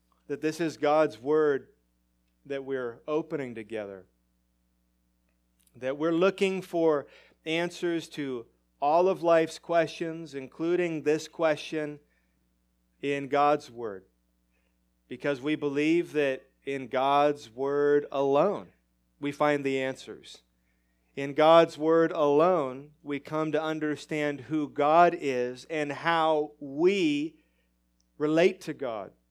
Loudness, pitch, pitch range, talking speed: -27 LUFS, 145 Hz, 105-160 Hz, 110 wpm